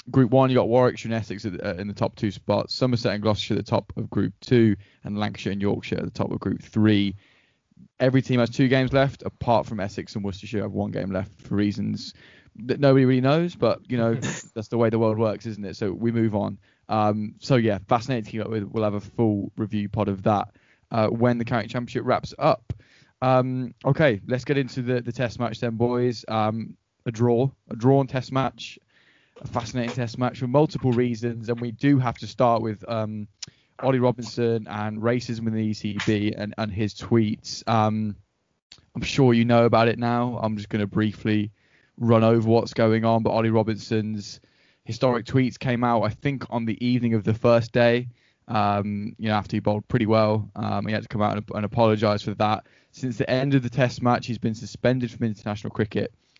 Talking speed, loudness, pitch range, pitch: 215 wpm, -24 LUFS, 105-125 Hz, 115 Hz